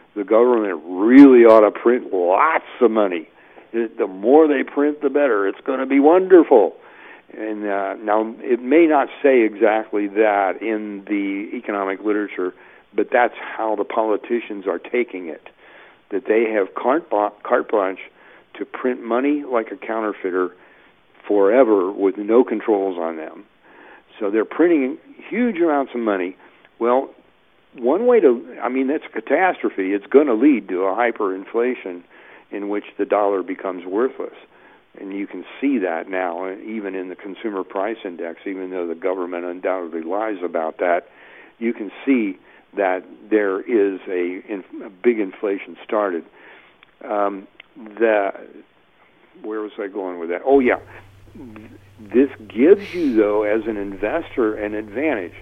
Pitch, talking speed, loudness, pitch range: 110 Hz, 150 wpm, -19 LUFS, 100-140 Hz